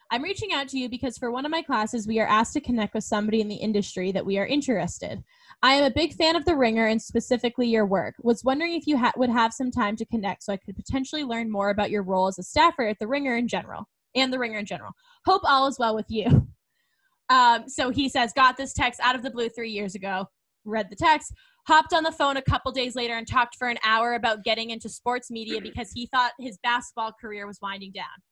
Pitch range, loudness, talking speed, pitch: 215-270 Hz, -25 LUFS, 255 wpm, 240 Hz